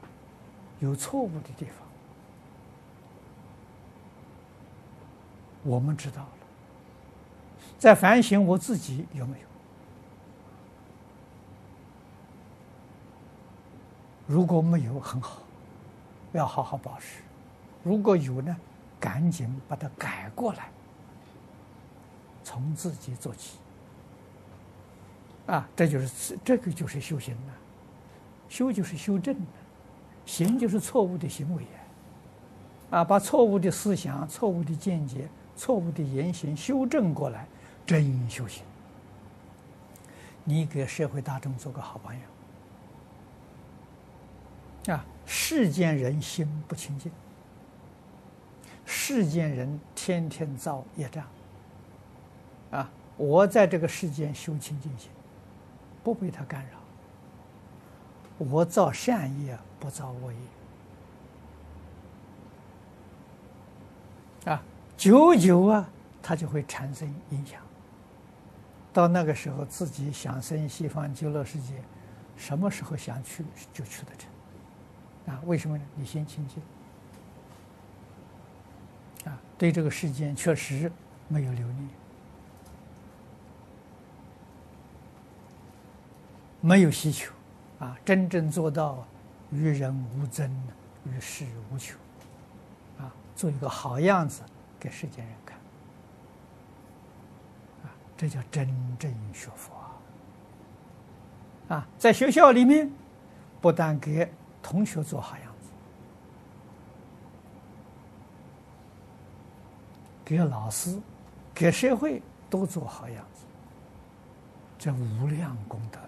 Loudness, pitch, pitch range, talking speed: -27 LUFS, 140 Hz, 115-165 Hz, 140 characters per minute